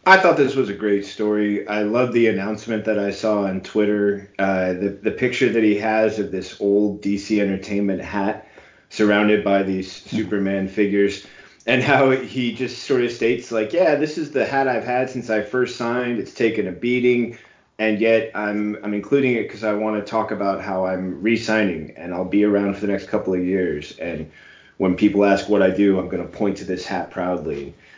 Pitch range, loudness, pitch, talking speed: 100-110 Hz, -20 LUFS, 105 Hz, 210 wpm